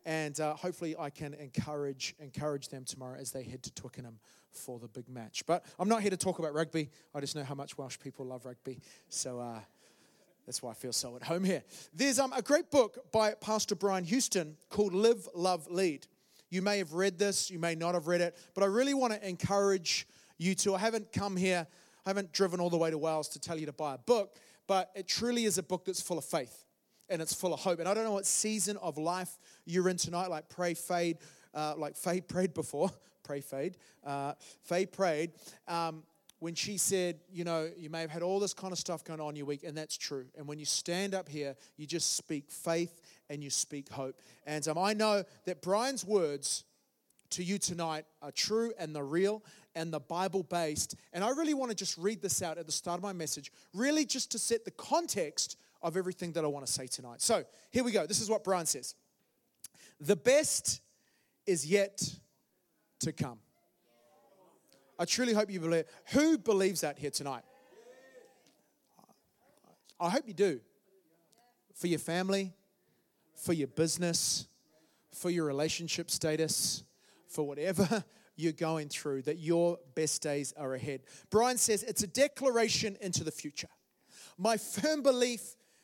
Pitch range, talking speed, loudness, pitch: 150-195 Hz, 195 wpm, -34 LUFS, 175 Hz